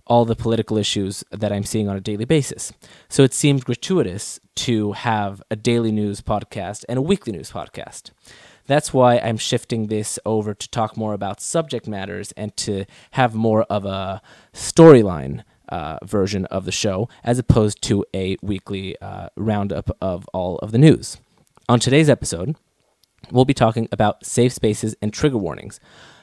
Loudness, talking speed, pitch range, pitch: -20 LUFS, 170 wpm, 100-120 Hz, 110 Hz